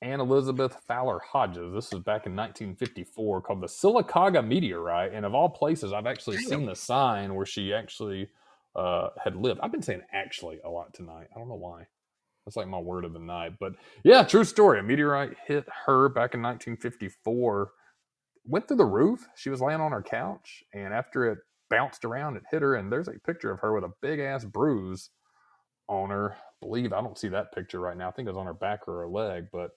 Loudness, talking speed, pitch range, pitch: -28 LUFS, 220 wpm, 90-130 Hz, 105 Hz